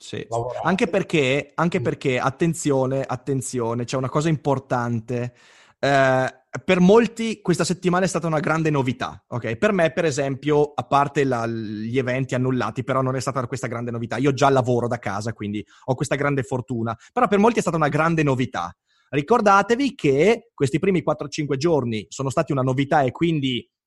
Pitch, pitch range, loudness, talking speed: 140 Hz, 125-160 Hz, -22 LUFS, 175 wpm